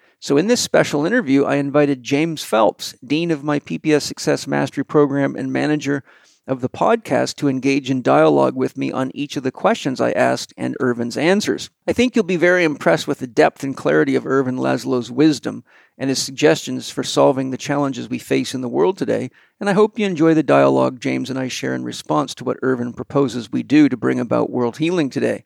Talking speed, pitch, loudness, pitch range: 210 wpm, 140 Hz, -18 LUFS, 125-155 Hz